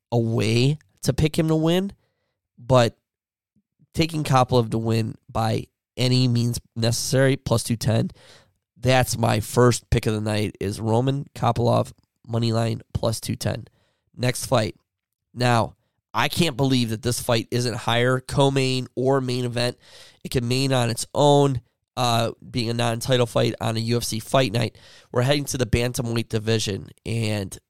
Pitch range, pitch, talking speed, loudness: 115-130 Hz, 120 Hz, 160 wpm, -23 LUFS